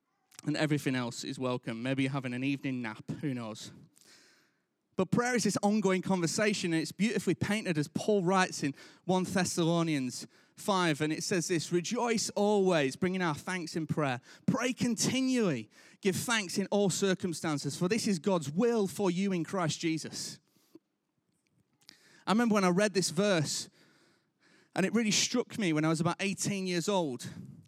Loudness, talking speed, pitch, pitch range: -31 LUFS, 165 wpm, 180 Hz, 155-205 Hz